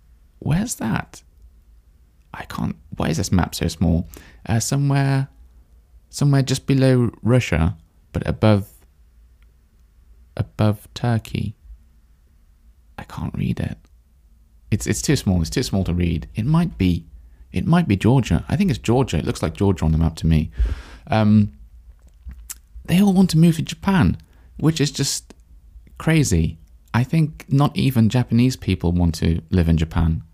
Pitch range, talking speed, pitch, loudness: 75-120 Hz, 150 wpm, 85 Hz, -20 LUFS